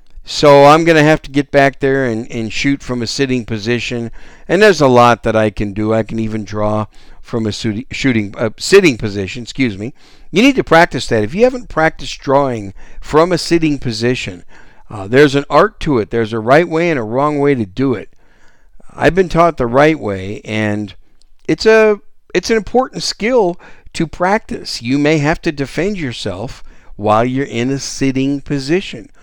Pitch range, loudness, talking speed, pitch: 110-160 Hz, -14 LUFS, 195 wpm, 135 Hz